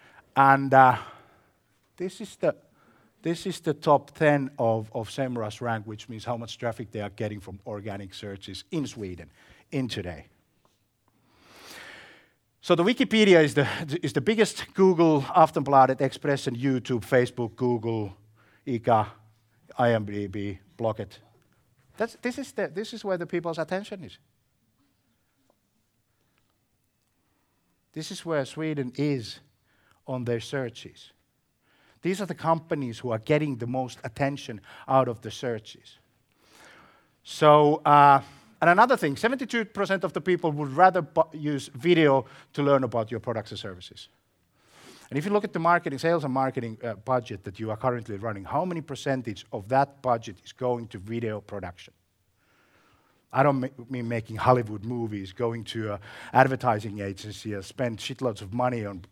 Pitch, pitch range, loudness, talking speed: 125 Hz, 110-145 Hz, -26 LUFS, 150 wpm